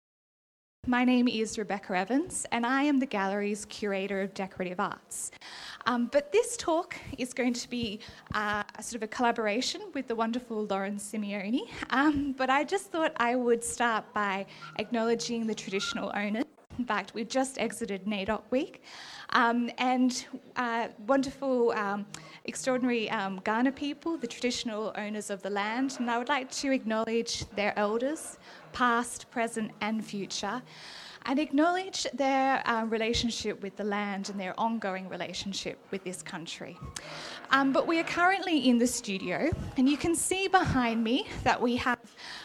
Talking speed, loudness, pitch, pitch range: 160 wpm, -30 LUFS, 235 Hz, 210-265 Hz